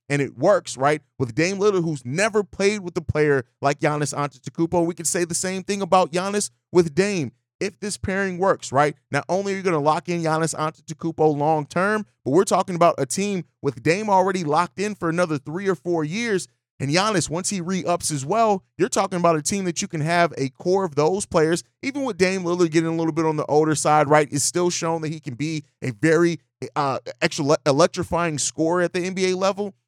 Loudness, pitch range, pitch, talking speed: -22 LUFS, 150-185 Hz, 170 Hz, 220 wpm